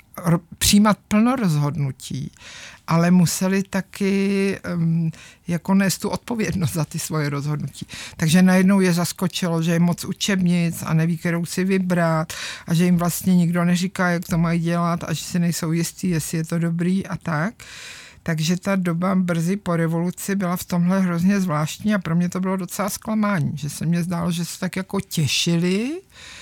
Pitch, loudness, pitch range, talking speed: 175 Hz, -21 LUFS, 165-190 Hz, 175 wpm